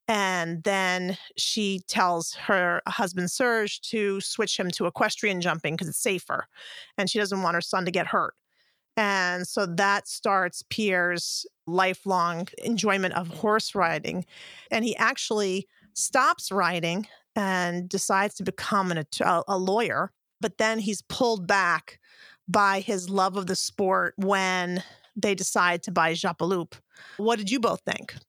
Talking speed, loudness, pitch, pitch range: 150 wpm, -26 LUFS, 195 Hz, 180-215 Hz